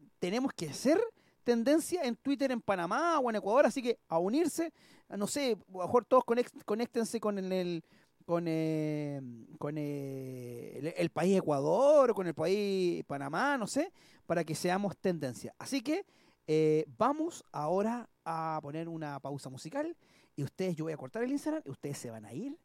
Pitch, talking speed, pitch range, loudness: 190 Hz, 175 wpm, 155-260 Hz, -33 LUFS